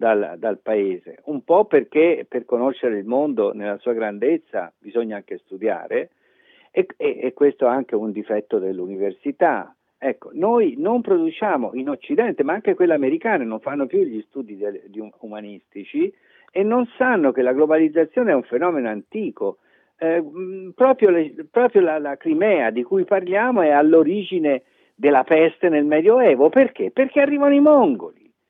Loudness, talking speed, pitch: -19 LUFS, 160 wpm, 185 Hz